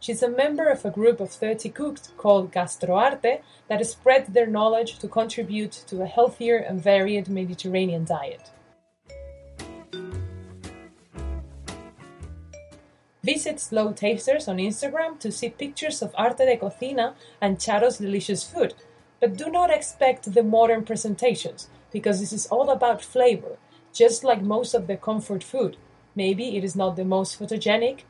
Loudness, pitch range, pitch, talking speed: -24 LUFS, 185-245 Hz, 215 Hz, 145 wpm